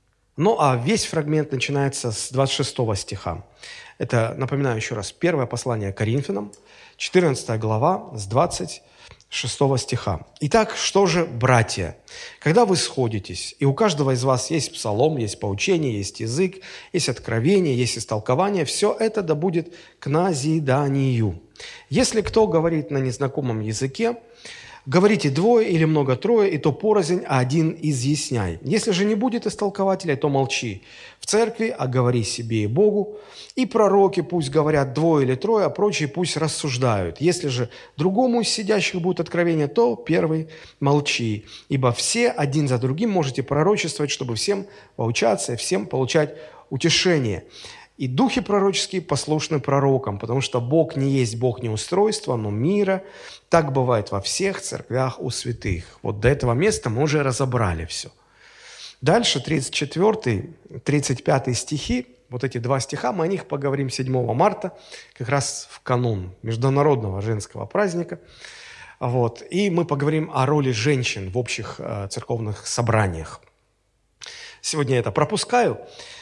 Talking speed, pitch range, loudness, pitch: 140 wpm, 125-180 Hz, -22 LUFS, 140 Hz